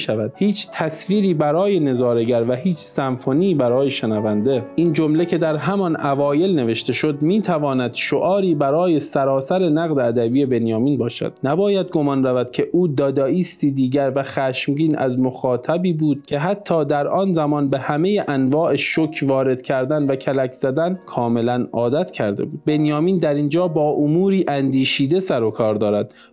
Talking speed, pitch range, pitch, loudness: 150 wpm, 130-165 Hz, 145 Hz, -19 LUFS